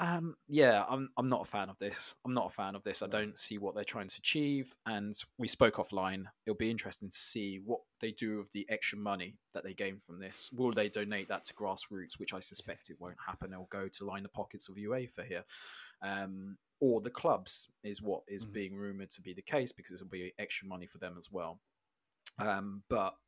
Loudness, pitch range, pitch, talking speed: -36 LUFS, 95-110 Hz, 100 Hz, 230 wpm